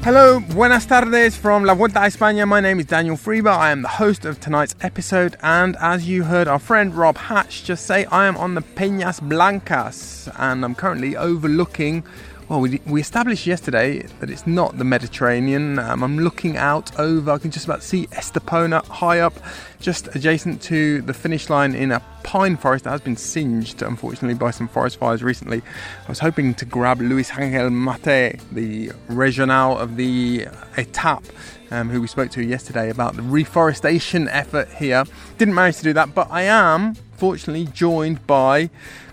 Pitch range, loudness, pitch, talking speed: 130-180 Hz, -18 LUFS, 155 Hz, 180 wpm